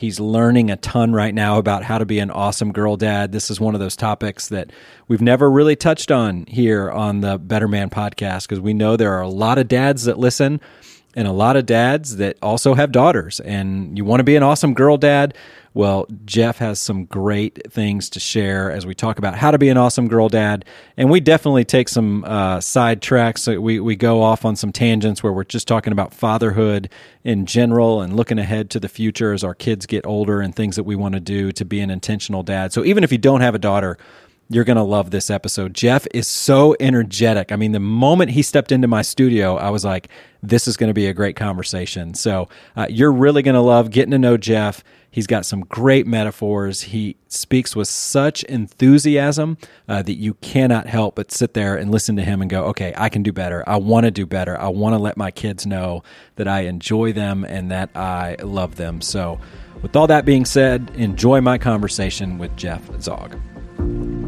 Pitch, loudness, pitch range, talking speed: 110 Hz, -17 LUFS, 100-120 Hz, 225 wpm